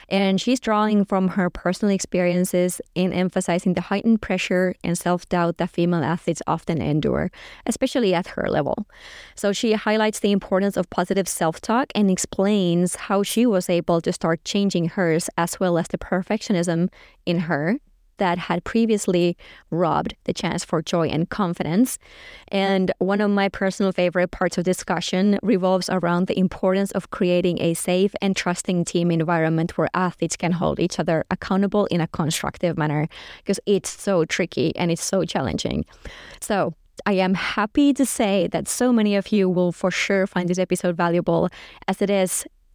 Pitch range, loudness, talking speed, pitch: 175-200 Hz, -22 LUFS, 170 wpm, 185 Hz